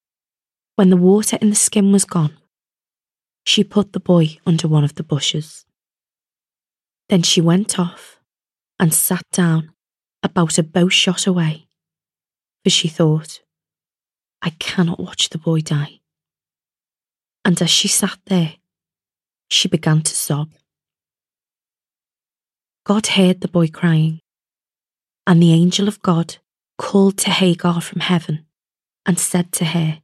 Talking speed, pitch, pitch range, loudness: 130 wpm, 175 Hz, 165-190 Hz, -16 LUFS